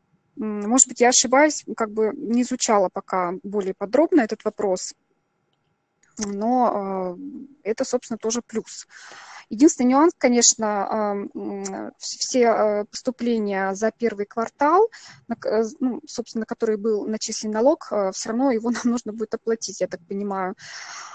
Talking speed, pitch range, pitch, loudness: 115 wpm, 205-250 Hz, 225 Hz, -22 LUFS